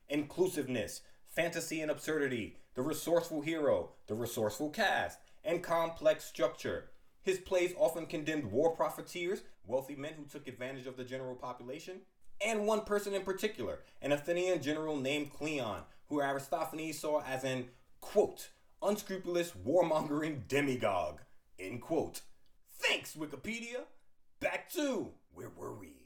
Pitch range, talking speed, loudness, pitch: 140-180 Hz, 130 wpm, -36 LUFS, 155 Hz